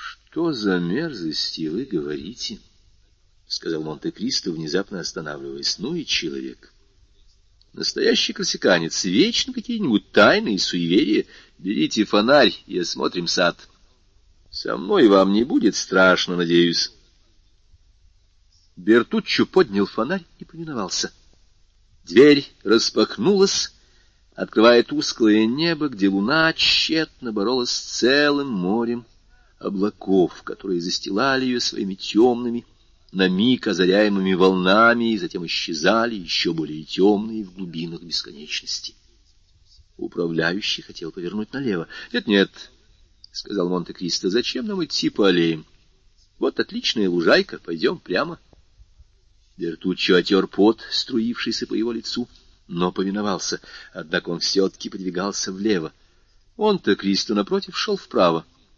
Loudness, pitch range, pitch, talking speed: -21 LUFS, 90-120 Hz, 95 Hz, 105 wpm